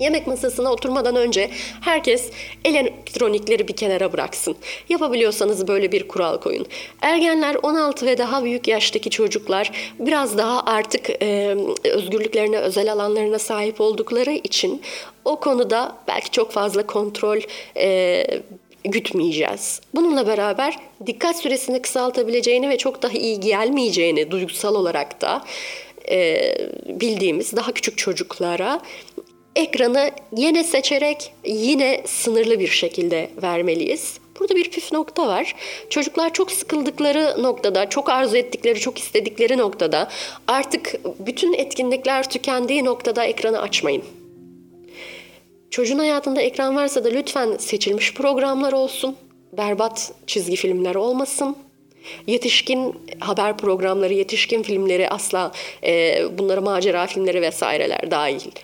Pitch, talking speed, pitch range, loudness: 255 Hz, 115 wpm, 215-315 Hz, -20 LUFS